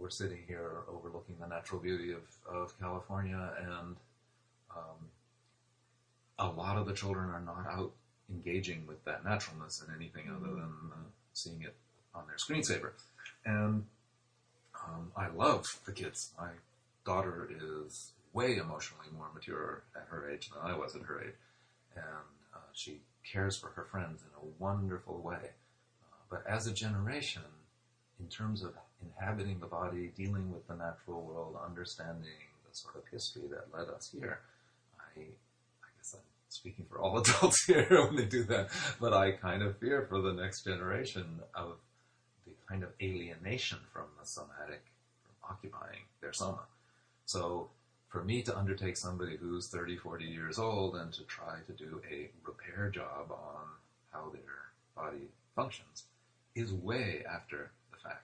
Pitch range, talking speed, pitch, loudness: 85-110 Hz, 160 wpm, 95 Hz, -38 LUFS